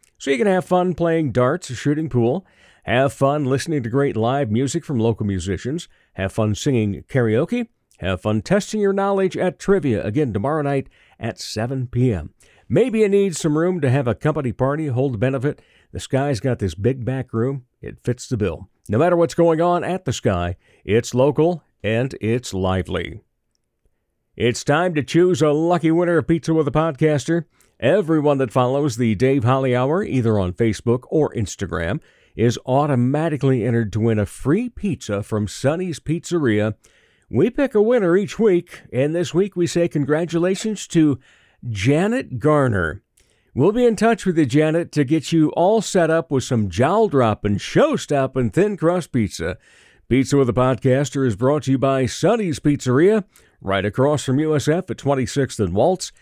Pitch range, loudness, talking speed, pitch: 120-165 Hz, -20 LUFS, 175 wpm, 140 Hz